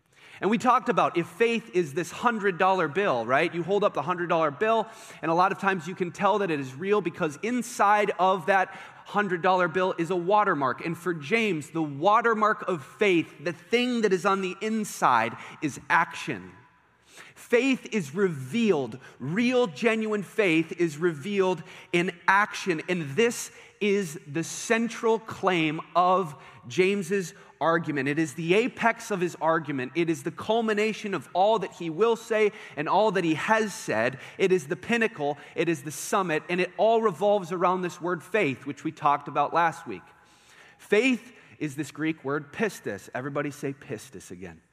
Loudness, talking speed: -26 LUFS, 170 wpm